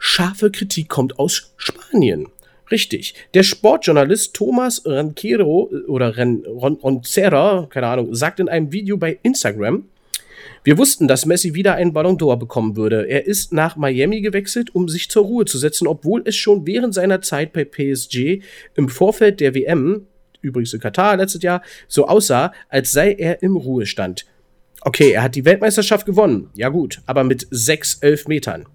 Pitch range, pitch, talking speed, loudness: 135-200 Hz, 165 Hz, 165 wpm, -17 LUFS